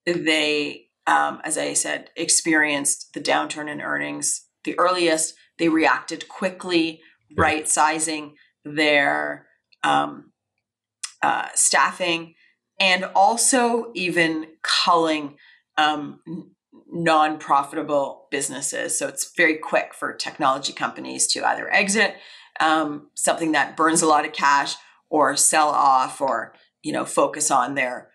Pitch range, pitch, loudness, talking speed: 150-170 Hz, 160 Hz, -21 LUFS, 115 wpm